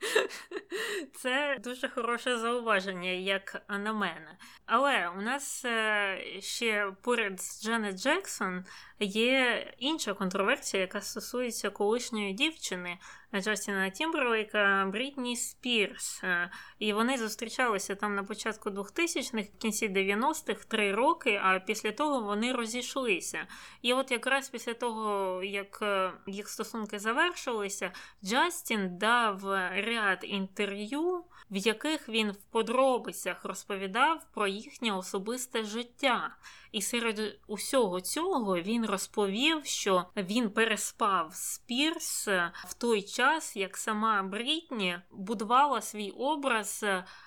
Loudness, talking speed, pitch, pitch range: -31 LUFS, 110 wpm, 220 Hz, 200-255 Hz